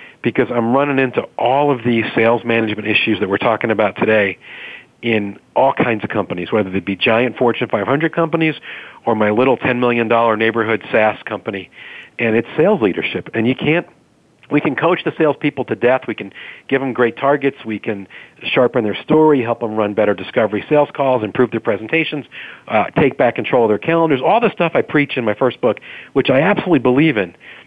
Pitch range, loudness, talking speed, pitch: 110-145 Hz, -16 LUFS, 195 wpm, 125 Hz